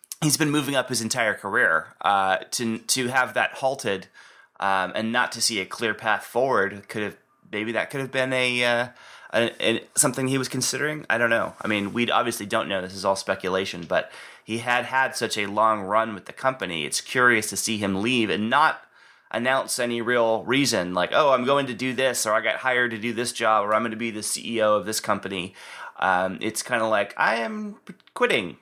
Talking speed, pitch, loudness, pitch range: 220 wpm, 115 Hz, -23 LUFS, 105-130 Hz